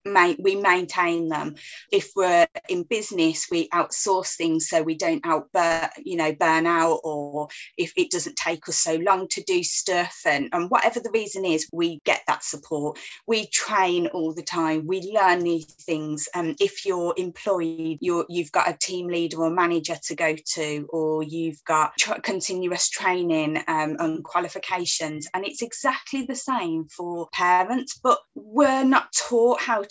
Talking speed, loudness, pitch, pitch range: 175 wpm, -24 LUFS, 175 Hz, 160-215 Hz